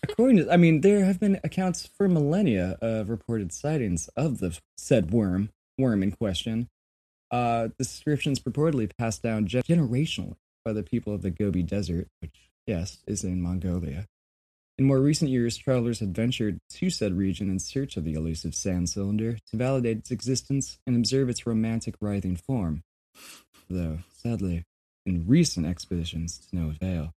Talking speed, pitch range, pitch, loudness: 160 wpm, 85-130 Hz, 105 Hz, -27 LUFS